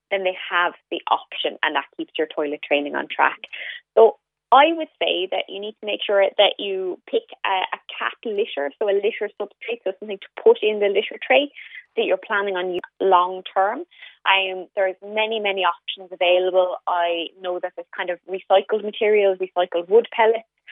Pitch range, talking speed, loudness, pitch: 180-230 Hz, 190 wpm, -21 LUFS, 200 Hz